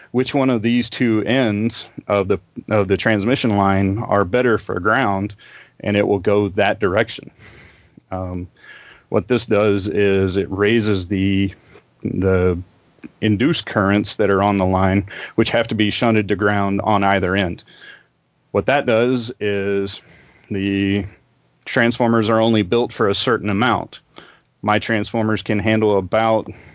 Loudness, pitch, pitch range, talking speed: -18 LUFS, 105 Hz, 100-115 Hz, 150 wpm